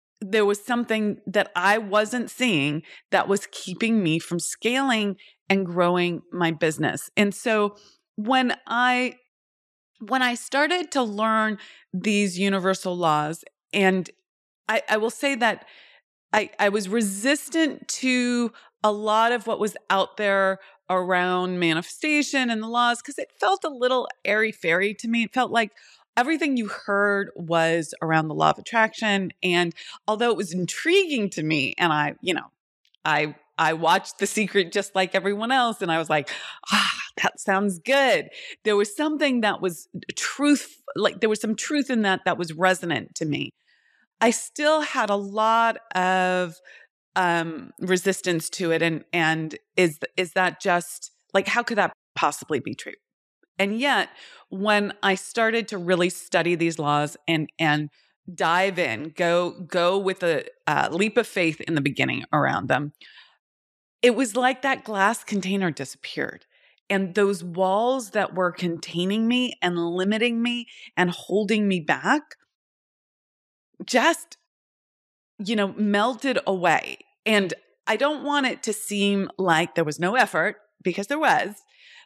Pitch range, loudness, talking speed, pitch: 180-235 Hz, -23 LUFS, 155 wpm, 200 Hz